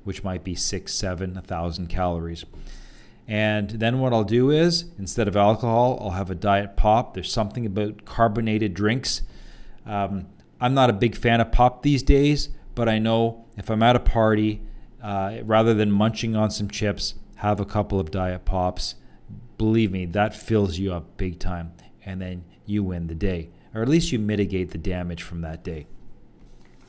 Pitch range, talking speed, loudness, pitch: 95-115 Hz, 185 wpm, -23 LUFS, 105 Hz